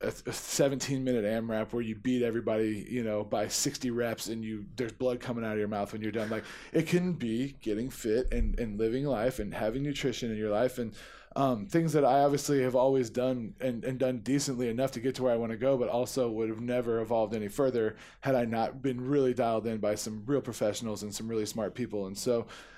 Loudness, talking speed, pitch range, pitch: -31 LUFS, 230 wpm, 110-130 Hz, 120 Hz